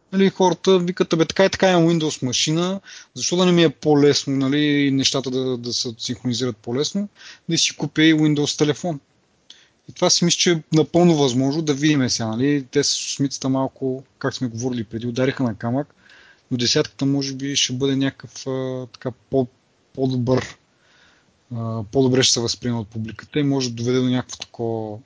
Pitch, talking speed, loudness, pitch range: 135 Hz, 180 wpm, -20 LUFS, 125-155 Hz